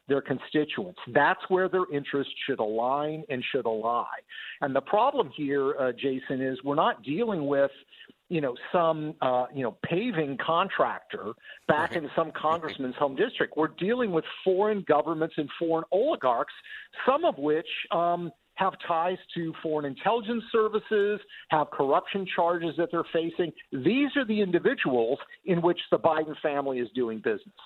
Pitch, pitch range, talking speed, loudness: 160 Hz, 140-185 Hz, 155 wpm, -28 LUFS